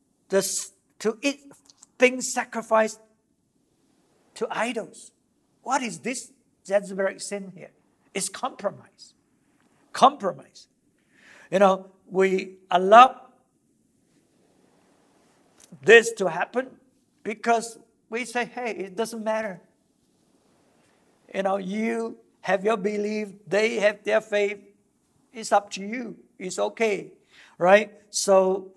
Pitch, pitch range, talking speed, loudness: 215 Hz, 195-240 Hz, 100 wpm, -24 LUFS